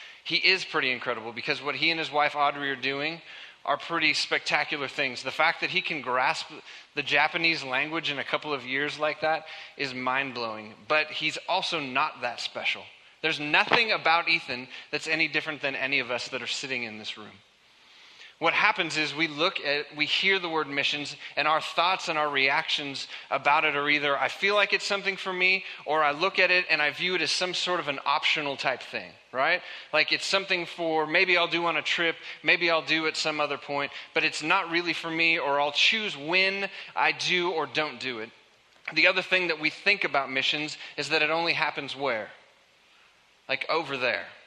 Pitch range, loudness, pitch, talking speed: 140-170 Hz, -26 LUFS, 155 Hz, 210 wpm